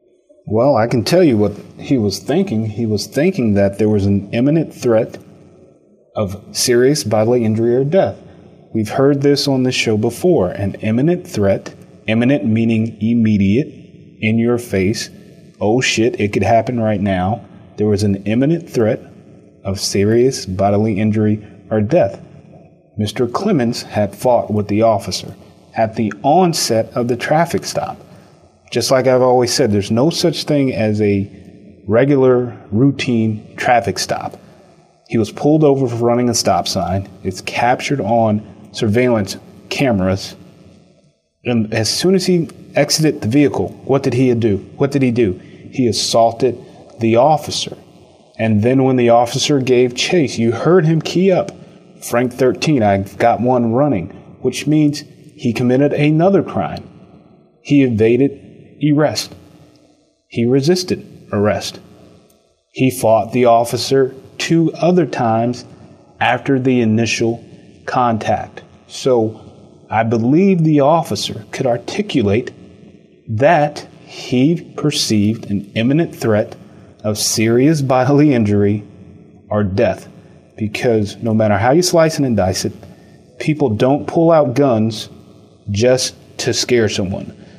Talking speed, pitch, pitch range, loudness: 140 wpm, 115 Hz, 105-135 Hz, -15 LUFS